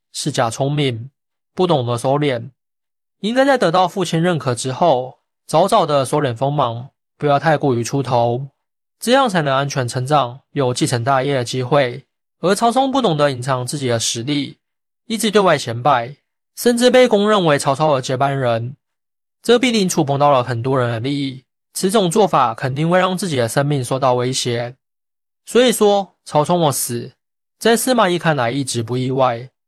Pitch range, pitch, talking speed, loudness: 130-180 Hz, 140 Hz, 260 characters per minute, -17 LUFS